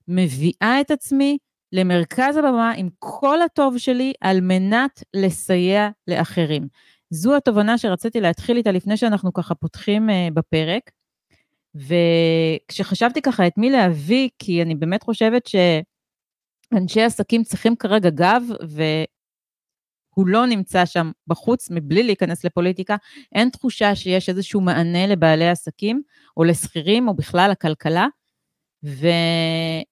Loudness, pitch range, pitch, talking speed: -19 LUFS, 170-230 Hz, 190 Hz, 115 wpm